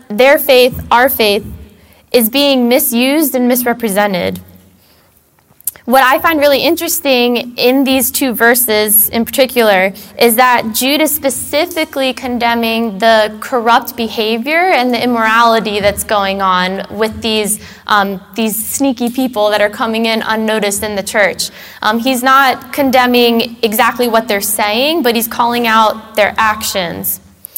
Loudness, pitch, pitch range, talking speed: -12 LUFS, 230 Hz, 210-260 Hz, 135 wpm